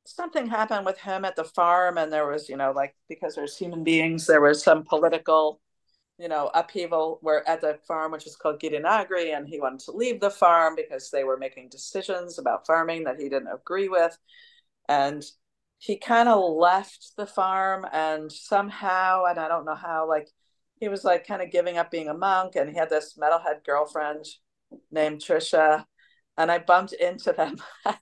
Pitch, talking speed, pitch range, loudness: 165 Hz, 190 wpm, 155-190 Hz, -25 LUFS